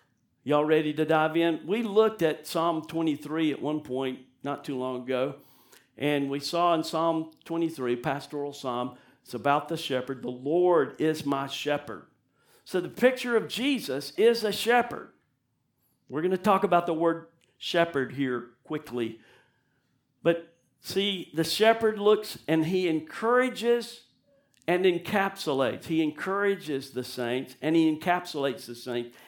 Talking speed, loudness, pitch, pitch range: 145 wpm, -28 LUFS, 155 Hz, 135-180 Hz